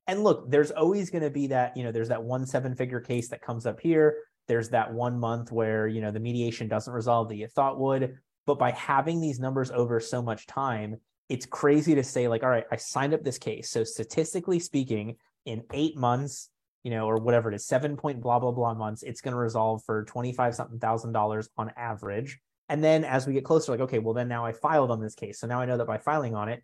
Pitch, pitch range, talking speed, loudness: 120 Hz, 115-140 Hz, 245 wpm, -28 LUFS